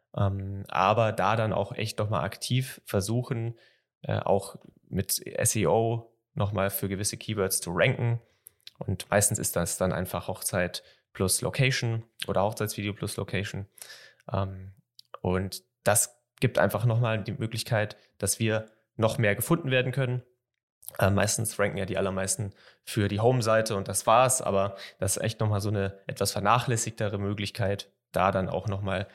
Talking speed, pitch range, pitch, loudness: 140 wpm, 100-115 Hz, 105 Hz, -28 LUFS